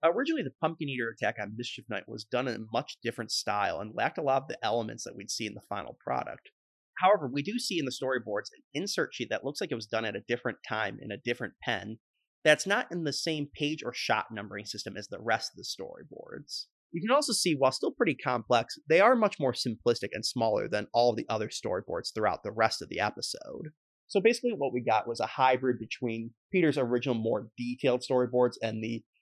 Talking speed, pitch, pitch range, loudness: 230 wpm, 125 Hz, 110-145 Hz, -31 LUFS